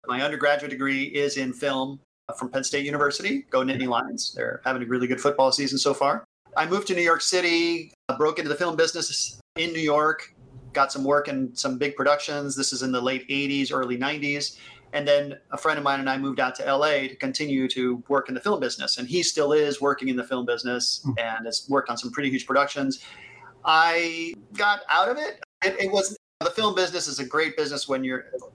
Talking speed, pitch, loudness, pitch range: 220 wpm, 140 Hz, -25 LUFS, 130-155 Hz